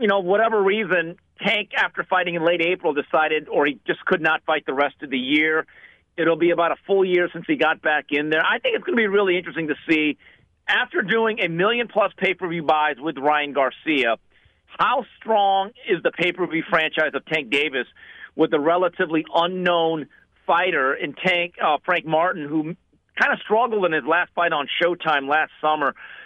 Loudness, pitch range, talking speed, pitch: -21 LUFS, 155-190 Hz, 195 wpm, 170 Hz